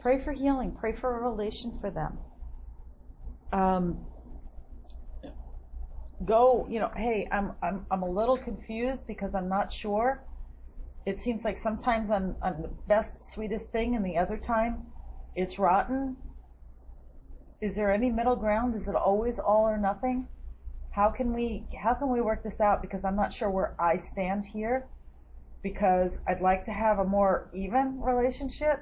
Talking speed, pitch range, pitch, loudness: 160 wpm, 175-230 Hz, 205 Hz, -29 LUFS